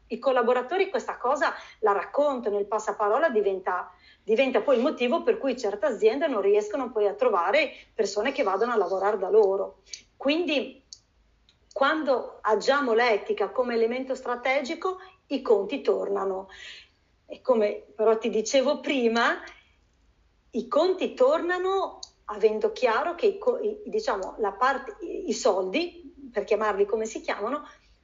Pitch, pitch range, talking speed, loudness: 260 Hz, 215-340 Hz, 135 wpm, -26 LUFS